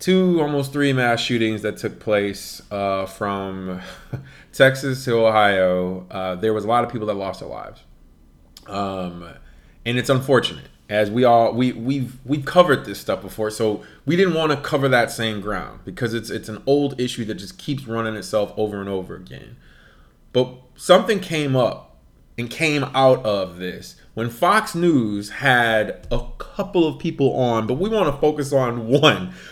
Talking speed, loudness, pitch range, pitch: 175 wpm, -20 LUFS, 100-140 Hz, 115 Hz